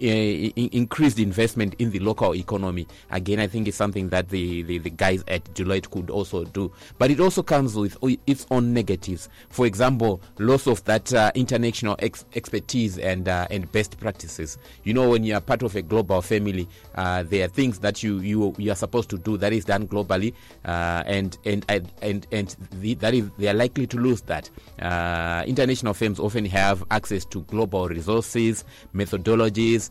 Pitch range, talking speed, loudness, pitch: 95-115 Hz, 195 wpm, -24 LUFS, 105 Hz